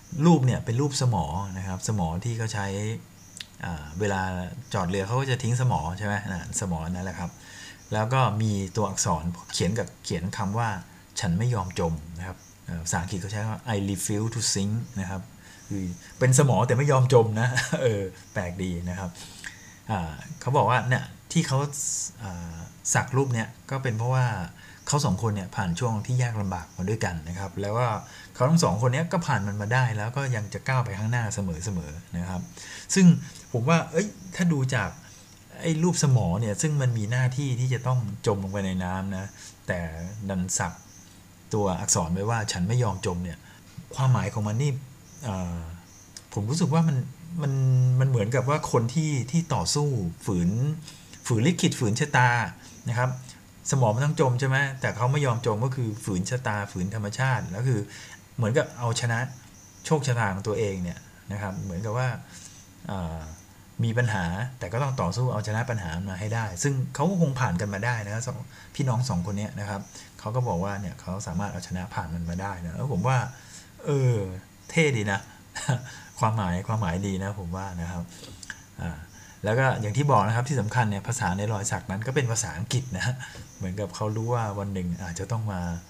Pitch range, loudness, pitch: 95-125 Hz, -27 LUFS, 105 Hz